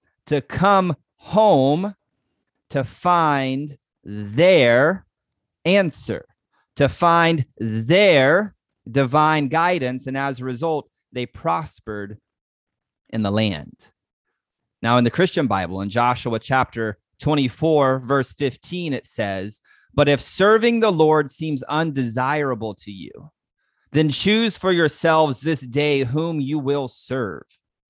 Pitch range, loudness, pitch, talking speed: 120-160 Hz, -20 LUFS, 140 Hz, 115 wpm